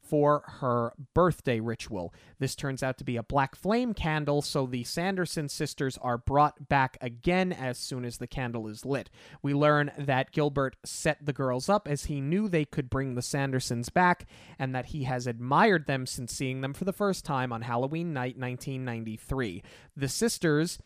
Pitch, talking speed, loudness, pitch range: 140 Hz, 185 wpm, -30 LUFS, 125-155 Hz